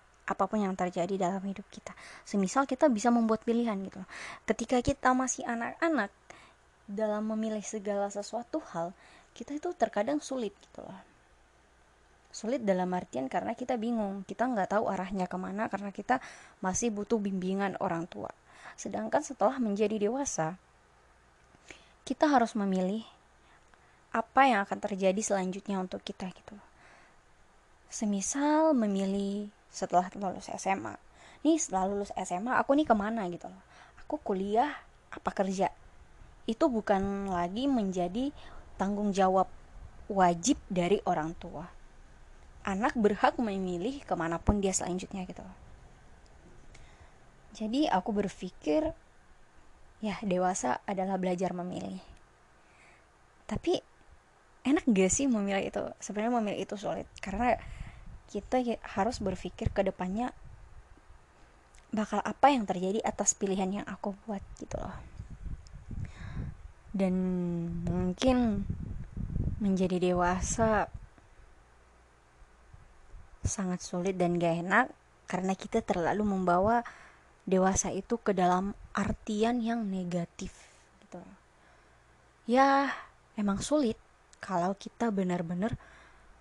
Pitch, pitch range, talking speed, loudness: 200 Hz, 185-230 Hz, 110 wpm, -31 LUFS